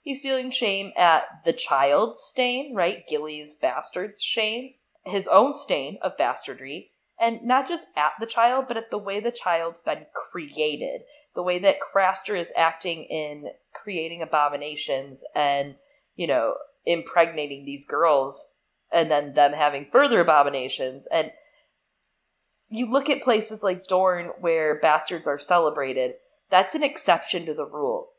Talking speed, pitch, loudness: 145 wpm, 190 Hz, -24 LUFS